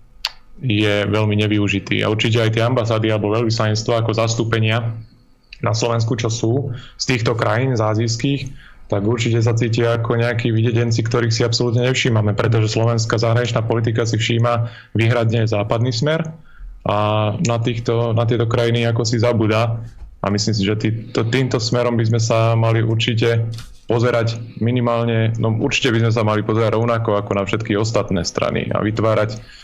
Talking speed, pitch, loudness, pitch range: 160 wpm, 115 Hz, -18 LUFS, 110-120 Hz